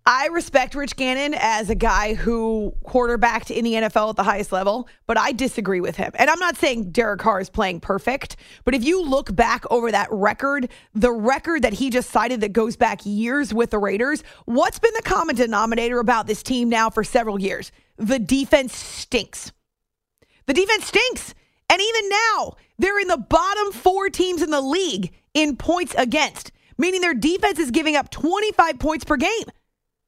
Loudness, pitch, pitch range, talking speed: -20 LUFS, 255 Hz, 225-325 Hz, 190 wpm